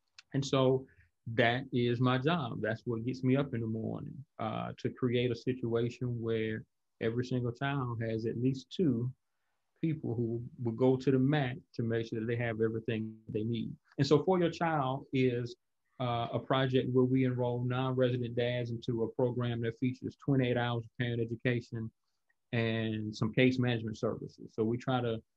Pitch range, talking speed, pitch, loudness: 115-130 Hz, 180 wpm, 120 Hz, -33 LUFS